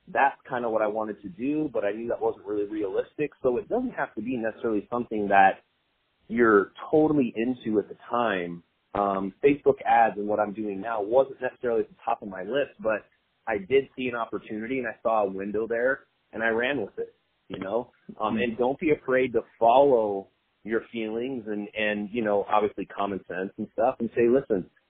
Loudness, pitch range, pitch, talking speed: -26 LUFS, 105-135 Hz, 115 Hz, 205 wpm